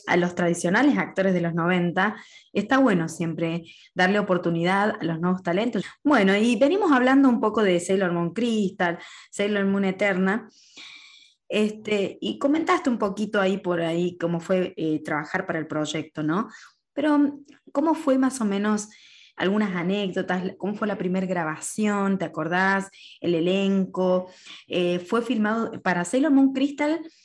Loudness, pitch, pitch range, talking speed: -24 LUFS, 195 Hz, 175-220 Hz, 150 wpm